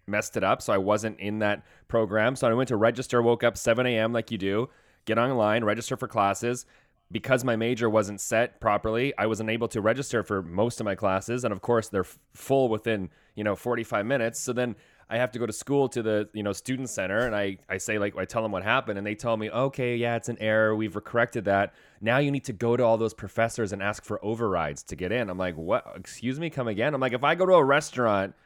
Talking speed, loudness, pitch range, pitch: 255 wpm, -27 LUFS, 105-120 Hz, 115 Hz